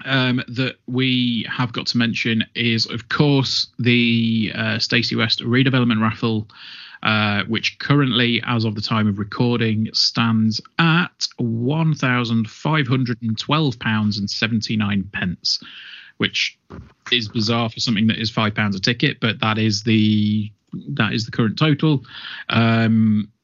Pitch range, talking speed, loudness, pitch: 110-125 Hz, 150 wpm, -19 LUFS, 115 Hz